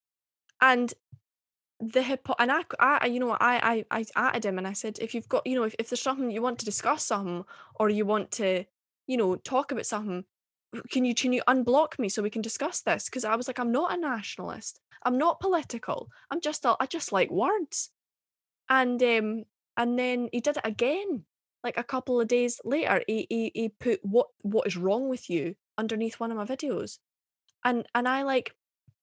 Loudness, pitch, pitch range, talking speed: -28 LUFS, 240 Hz, 220-260 Hz, 210 wpm